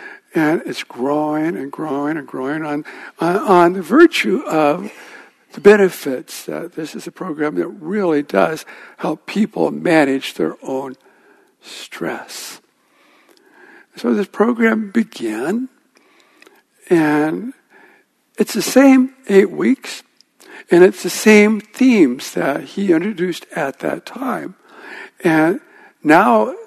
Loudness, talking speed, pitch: -16 LUFS, 115 wpm, 210 Hz